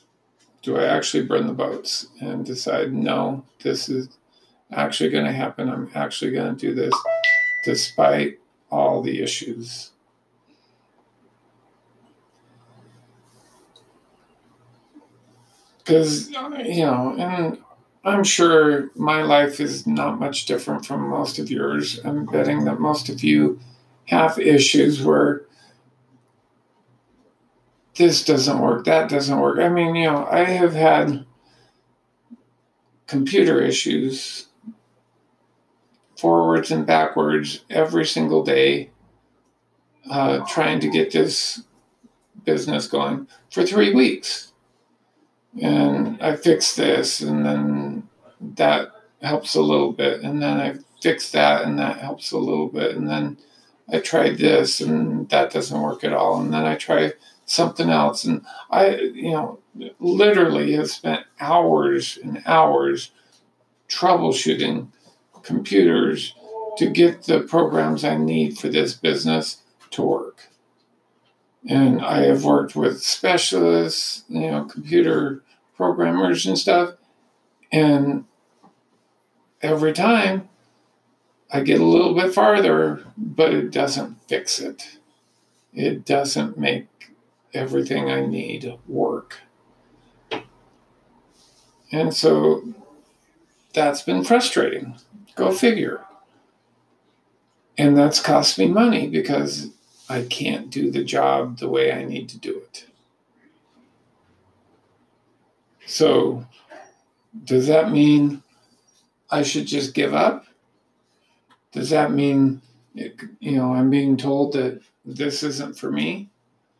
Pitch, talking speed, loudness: 125 Hz, 115 wpm, -20 LUFS